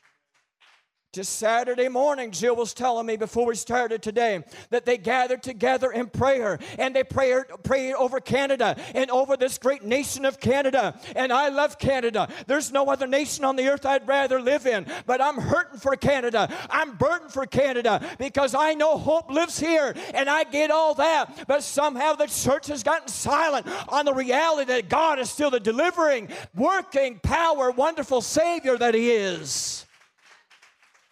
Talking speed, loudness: 170 wpm, -24 LUFS